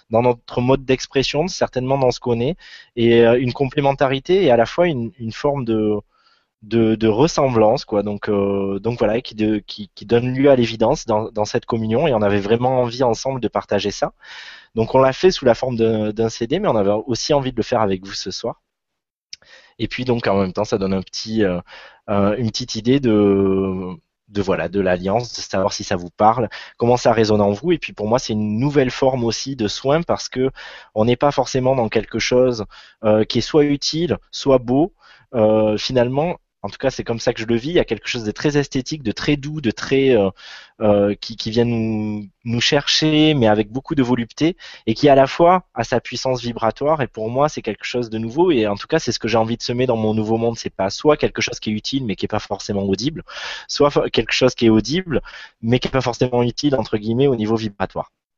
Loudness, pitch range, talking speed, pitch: -19 LUFS, 105-130 Hz, 235 wpm, 115 Hz